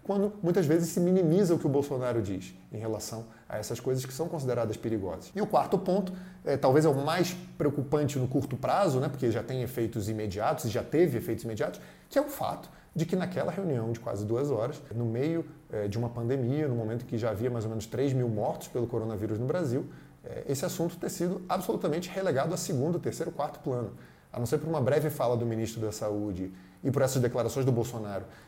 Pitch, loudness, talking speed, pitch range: 130 Hz, -30 LUFS, 225 wpm, 115-165 Hz